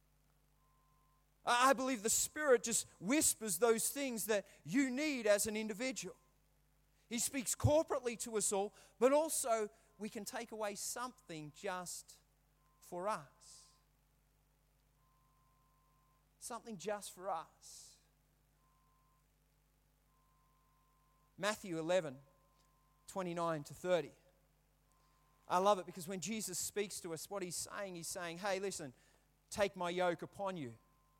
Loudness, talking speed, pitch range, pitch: -38 LUFS, 115 wpm, 150-220 Hz, 185 Hz